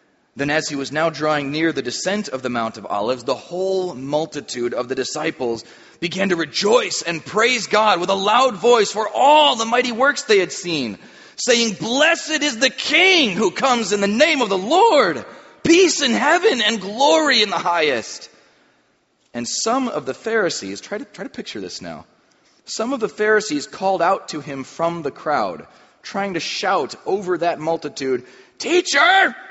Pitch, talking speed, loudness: 205 Hz, 180 wpm, -18 LUFS